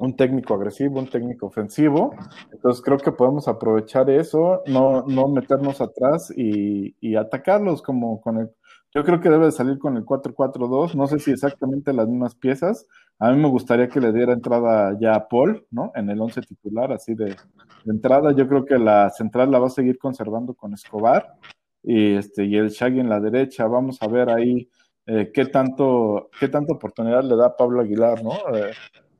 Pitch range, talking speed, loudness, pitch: 110-135 Hz, 195 wpm, -20 LUFS, 125 Hz